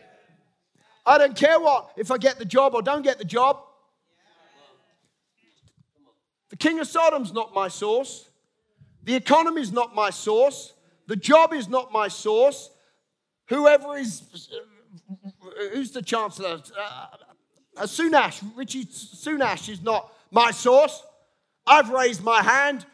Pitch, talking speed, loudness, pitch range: 250 Hz, 130 wpm, -21 LUFS, 210-290 Hz